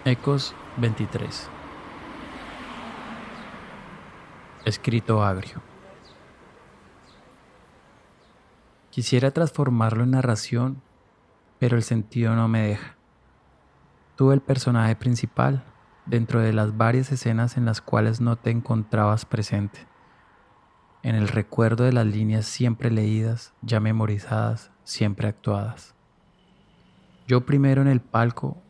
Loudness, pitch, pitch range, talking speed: -24 LUFS, 115 Hz, 110-125 Hz, 100 wpm